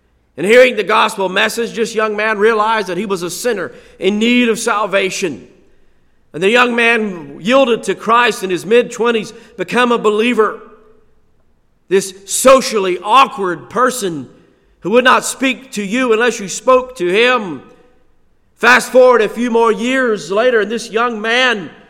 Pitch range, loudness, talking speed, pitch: 205-245 Hz, -13 LUFS, 155 wpm, 225 Hz